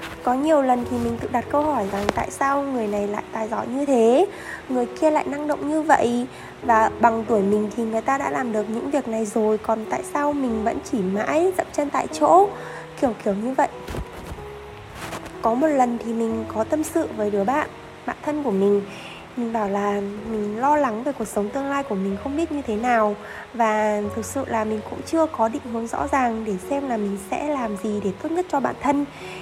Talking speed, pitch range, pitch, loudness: 230 wpm, 210-280 Hz, 230 Hz, -23 LUFS